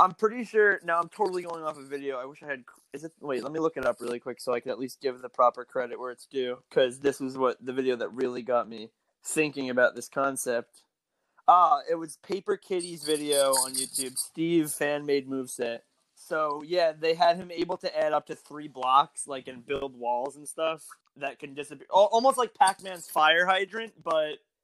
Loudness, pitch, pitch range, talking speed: -28 LUFS, 145 Hz, 130-170 Hz, 220 wpm